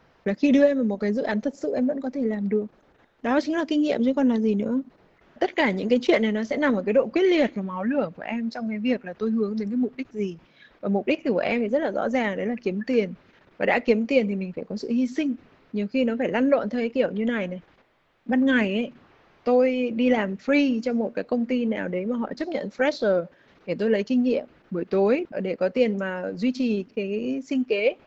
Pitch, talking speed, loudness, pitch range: 240 Hz, 280 wpm, -25 LUFS, 210-265 Hz